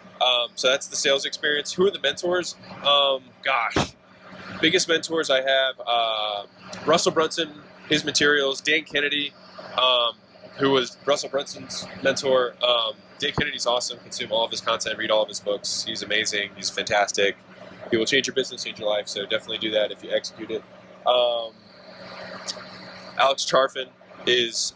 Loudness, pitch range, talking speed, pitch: -23 LUFS, 115-150 Hz, 160 wpm, 135 Hz